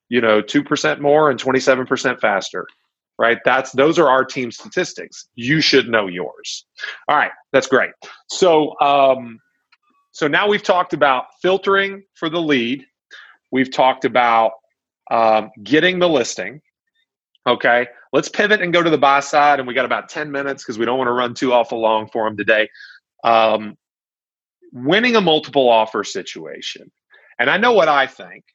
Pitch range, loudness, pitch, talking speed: 120-165 Hz, -17 LUFS, 135 Hz, 170 wpm